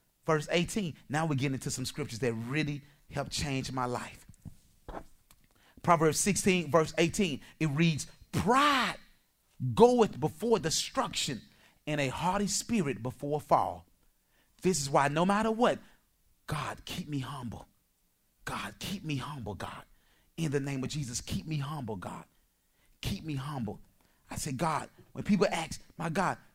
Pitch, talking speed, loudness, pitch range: 145 Hz, 145 wpm, -31 LUFS, 125-170 Hz